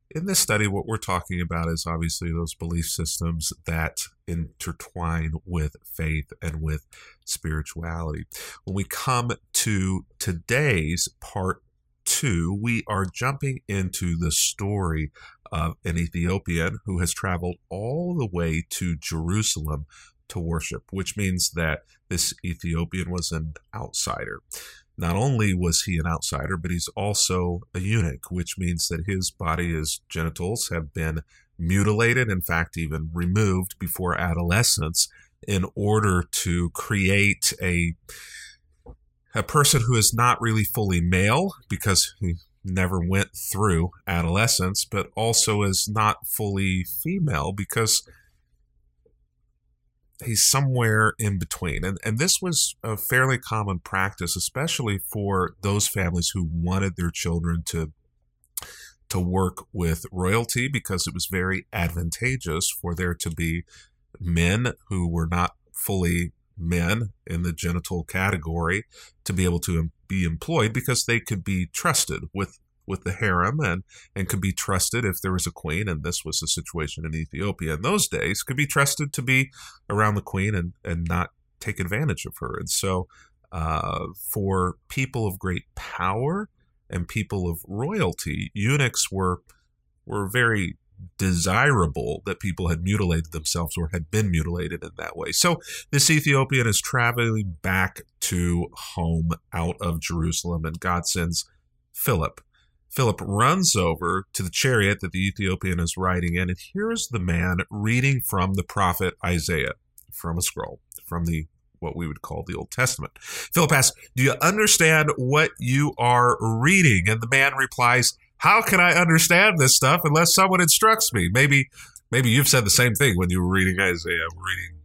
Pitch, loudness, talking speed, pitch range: 90 Hz, -23 LUFS, 150 wpm, 85-110 Hz